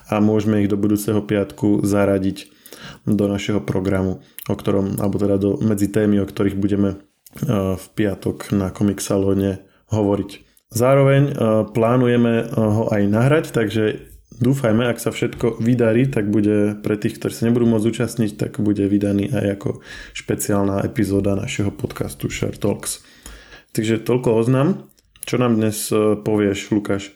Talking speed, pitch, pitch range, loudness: 140 wpm, 105 Hz, 100-115 Hz, -19 LUFS